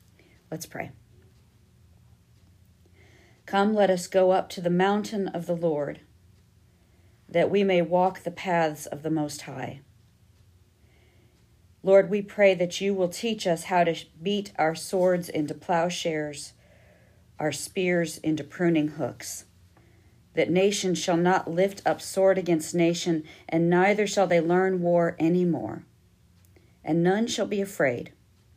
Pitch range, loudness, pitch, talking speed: 145-185 Hz, -25 LUFS, 170 Hz, 135 wpm